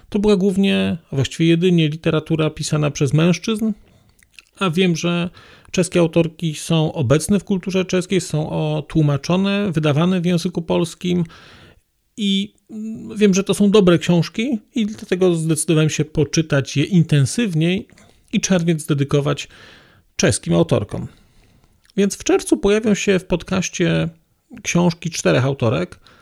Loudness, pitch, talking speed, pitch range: -18 LUFS, 175 Hz, 125 wpm, 155-195 Hz